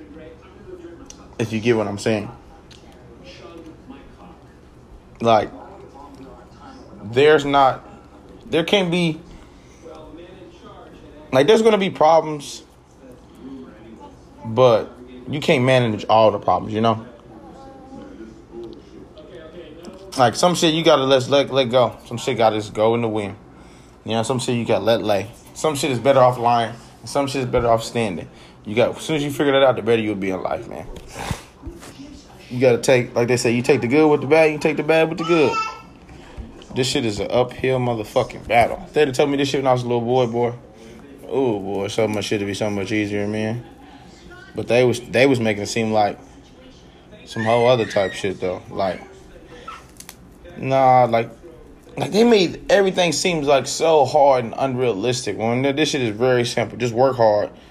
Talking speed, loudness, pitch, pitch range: 175 wpm, -19 LUFS, 125 Hz, 110-145 Hz